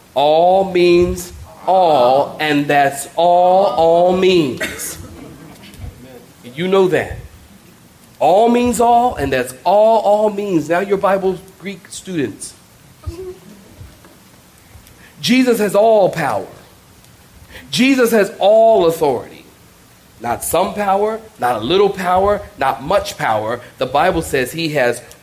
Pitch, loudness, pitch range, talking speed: 185 Hz, -15 LUFS, 165-210 Hz, 110 wpm